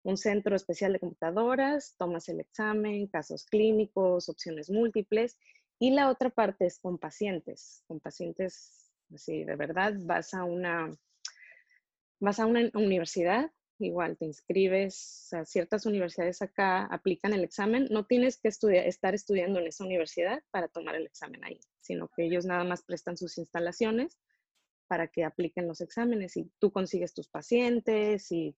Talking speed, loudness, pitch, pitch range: 155 wpm, -31 LUFS, 190 Hz, 175-215 Hz